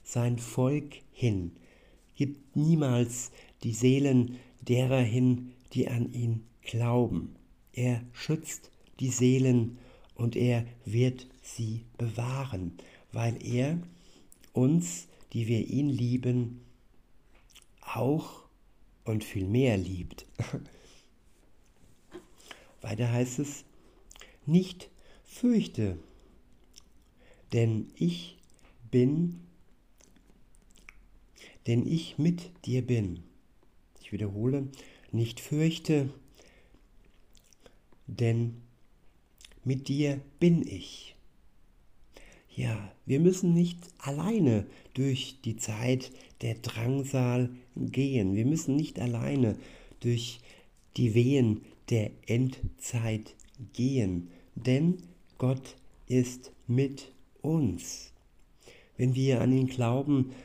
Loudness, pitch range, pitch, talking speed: -30 LUFS, 115-135 Hz, 125 Hz, 85 wpm